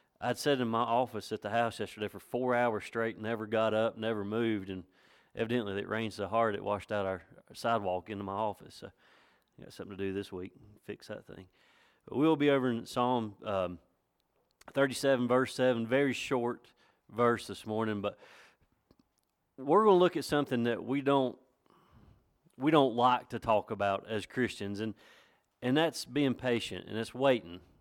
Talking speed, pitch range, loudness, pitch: 180 wpm, 100-125 Hz, -32 LUFS, 115 Hz